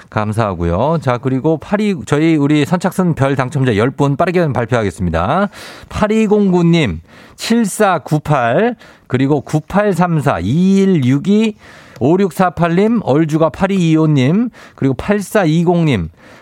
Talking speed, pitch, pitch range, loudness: 160 characters per minute, 160 Hz, 135-195 Hz, -14 LUFS